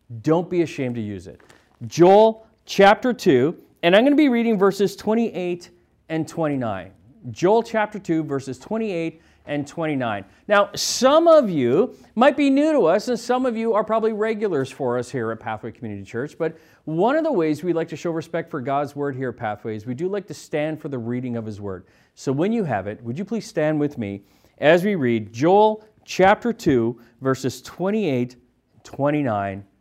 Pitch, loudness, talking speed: 155 Hz, -21 LUFS, 195 wpm